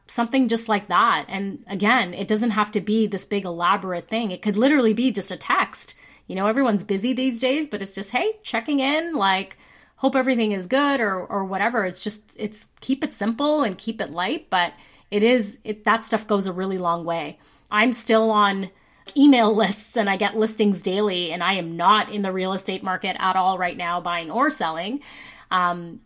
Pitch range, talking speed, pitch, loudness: 190-235 Hz, 205 wpm, 210 Hz, -22 LUFS